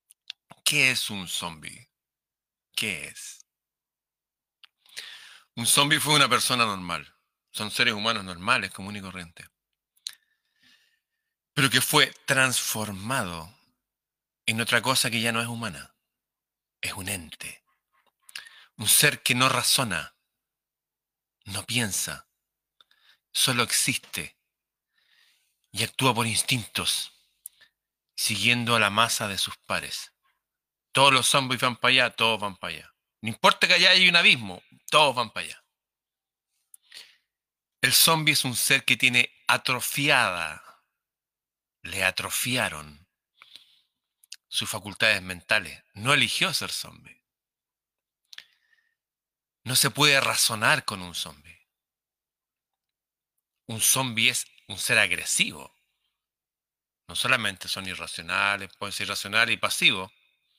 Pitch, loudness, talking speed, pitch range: 115 Hz, -23 LUFS, 115 wpm, 100-135 Hz